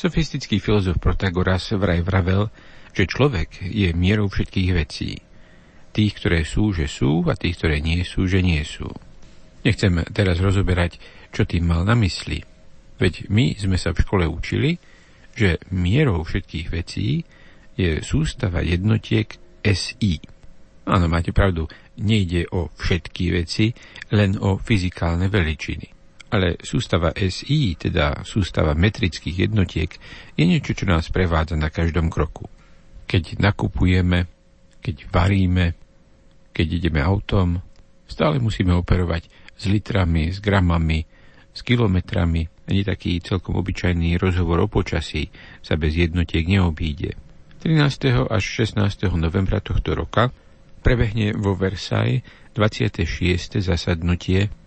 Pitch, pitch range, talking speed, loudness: 95 Hz, 85-105 Hz, 120 wpm, -21 LUFS